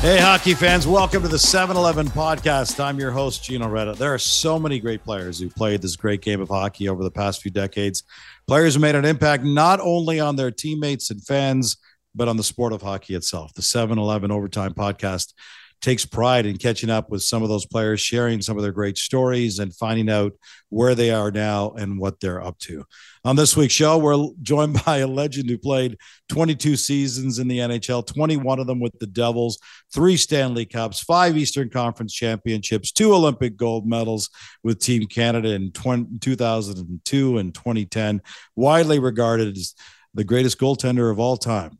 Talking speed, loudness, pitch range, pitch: 190 wpm, -20 LUFS, 105-140 Hz, 120 Hz